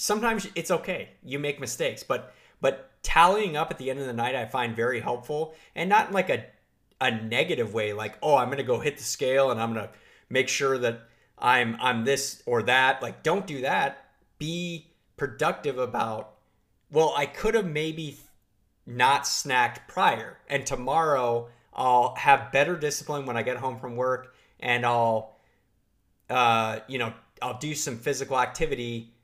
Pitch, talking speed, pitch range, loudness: 130 Hz, 170 wpm, 115-145 Hz, -26 LUFS